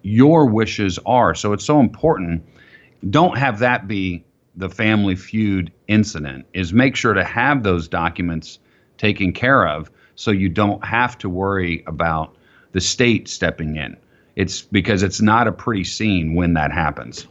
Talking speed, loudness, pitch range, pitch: 160 wpm, -18 LUFS, 85-110 Hz, 95 Hz